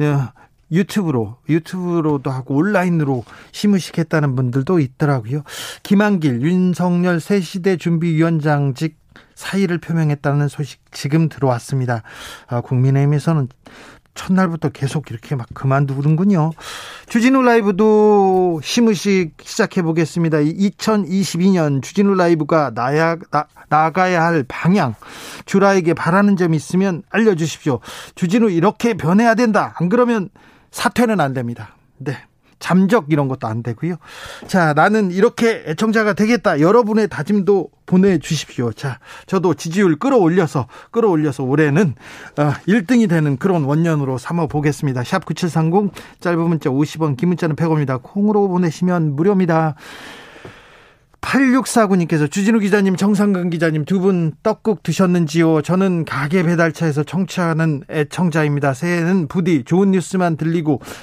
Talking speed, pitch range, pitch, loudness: 310 characters per minute, 150-195 Hz, 165 Hz, -17 LUFS